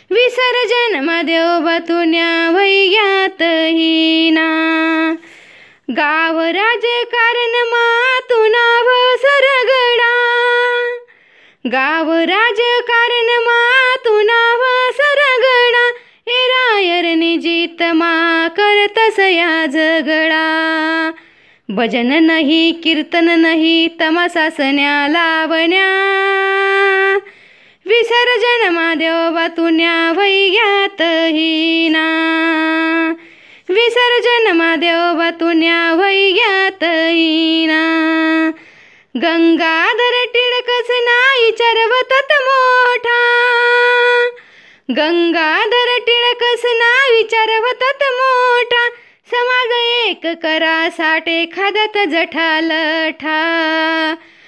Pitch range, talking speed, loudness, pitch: 325-475 Hz, 50 wpm, -12 LUFS, 345 Hz